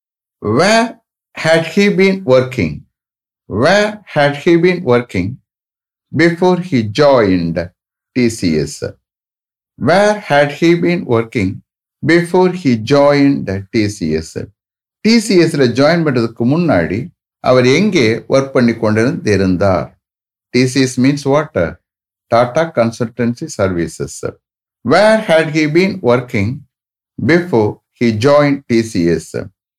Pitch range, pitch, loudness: 110-165 Hz, 130 Hz, -13 LUFS